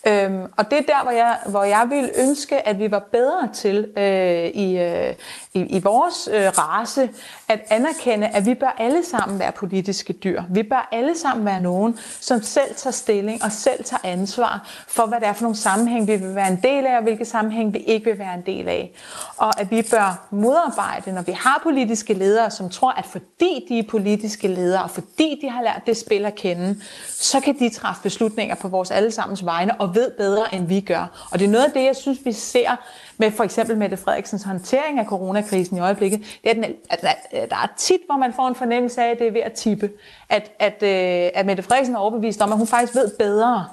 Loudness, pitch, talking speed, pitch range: -20 LUFS, 220 Hz, 225 wpm, 195-245 Hz